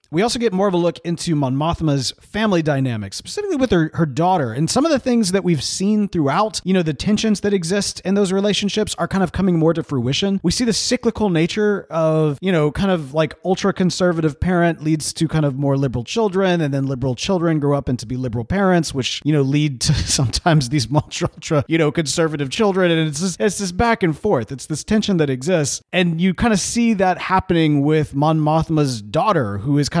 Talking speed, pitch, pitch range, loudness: 220 wpm, 170 Hz, 145-195 Hz, -18 LUFS